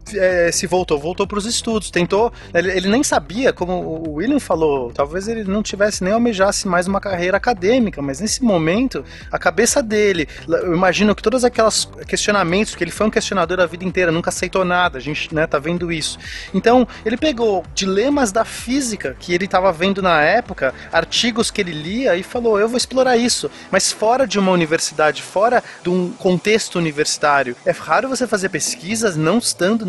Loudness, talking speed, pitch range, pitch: -17 LUFS, 190 wpm, 175-225 Hz, 195 Hz